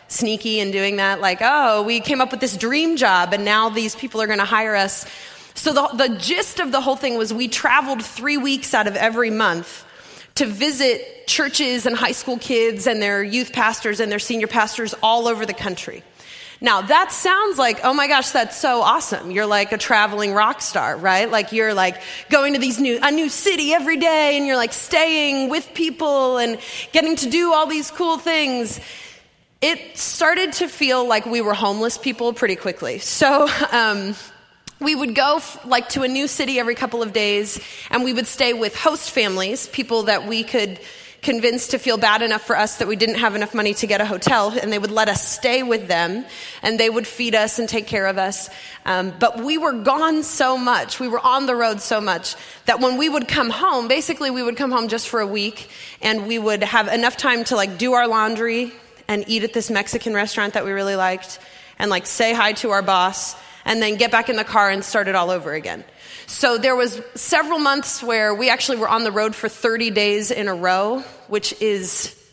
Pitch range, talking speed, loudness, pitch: 210-270 Hz, 220 wpm, -19 LUFS, 235 Hz